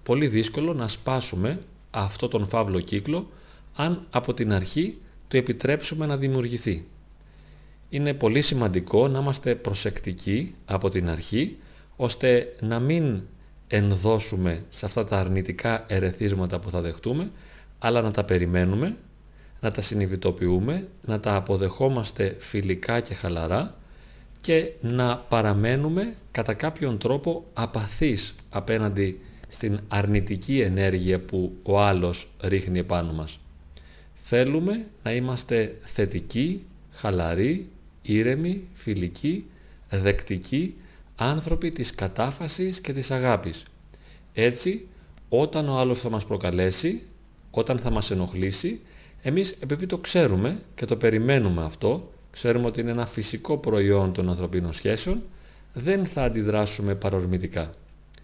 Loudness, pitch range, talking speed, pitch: -26 LUFS, 95-135 Hz, 115 wpm, 110 Hz